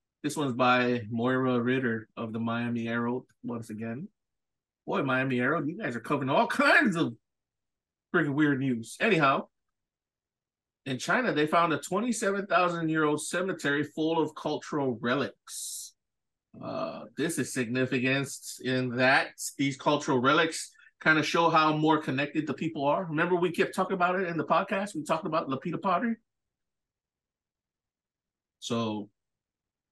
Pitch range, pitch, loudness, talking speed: 125-165 Hz, 140 Hz, -28 LUFS, 140 wpm